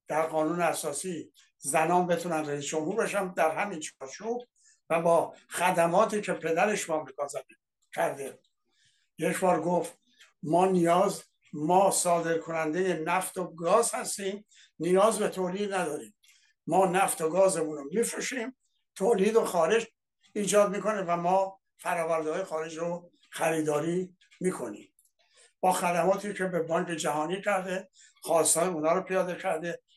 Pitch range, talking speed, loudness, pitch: 165-195 Hz, 130 wpm, -28 LUFS, 180 Hz